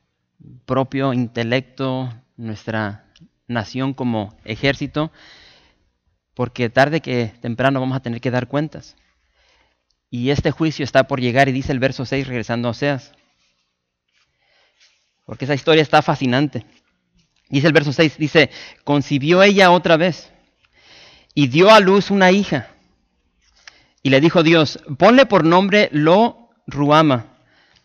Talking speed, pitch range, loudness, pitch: 125 wpm, 120-160 Hz, -16 LUFS, 135 Hz